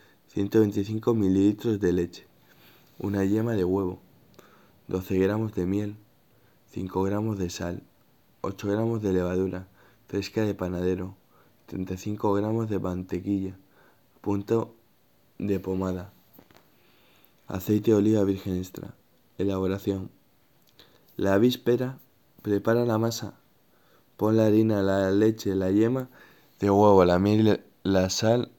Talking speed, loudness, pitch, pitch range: 115 wpm, -26 LUFS, 100 Hz, 95-110 Hz